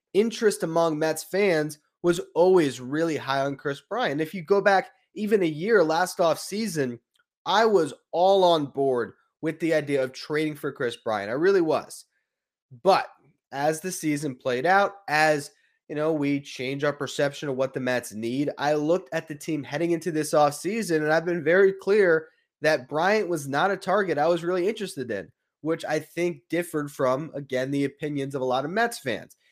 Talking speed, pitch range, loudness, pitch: 190 wpm, 145-185 Hz, -25 LUFS, 155 Hz